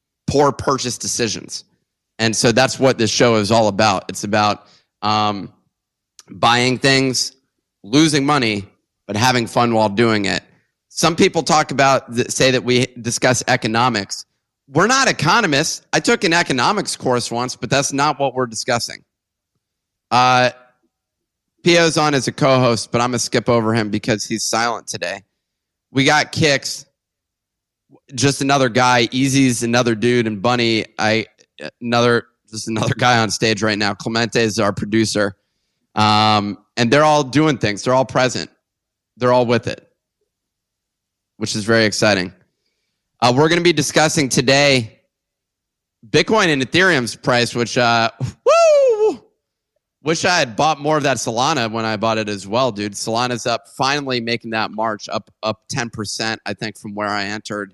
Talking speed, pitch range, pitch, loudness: 160 wpm, 105-130 Hz, 120 Hz, -17 LUFS